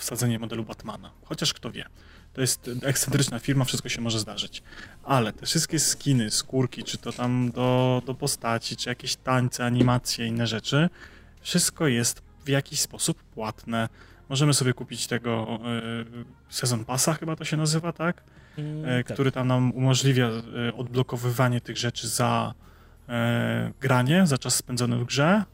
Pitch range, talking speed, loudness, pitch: 115-135 Hz, 145 wpm, -26 LUFS, 125 Hz